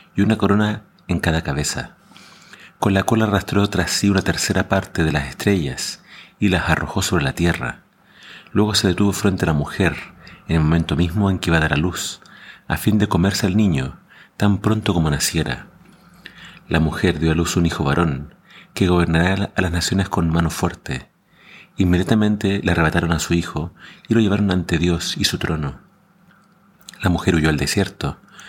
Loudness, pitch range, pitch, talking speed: -19 LUFS, 80-100 Hz, 90 Hz, 185 wpm